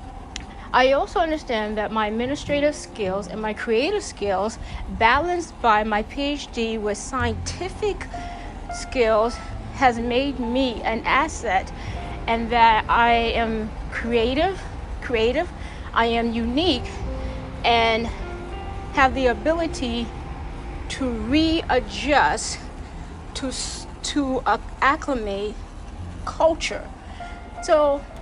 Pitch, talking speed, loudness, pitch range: 235 Hz, 90 wpm, -22 LUFS, 215-280 Hz